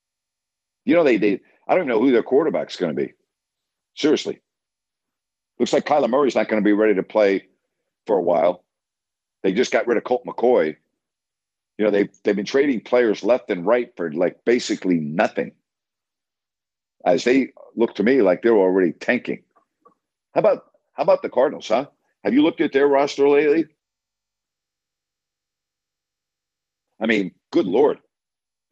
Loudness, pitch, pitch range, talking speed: -20 LUFS, 110 Hz, 90-140 Hz, 160 wpm